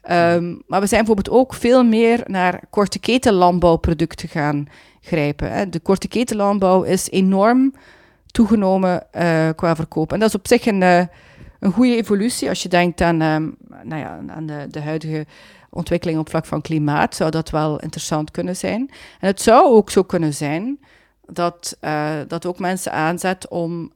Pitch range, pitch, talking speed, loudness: 160-205 Hz, 175 Hz, 180 wpm, -18 LUFS